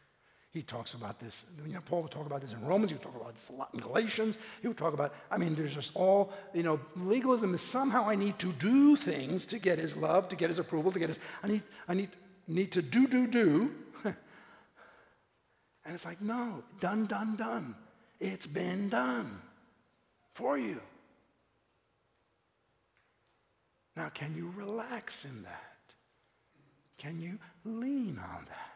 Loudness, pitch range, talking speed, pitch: -33 LUFS, 150-220 Hz, 175 wpm, 185 Hz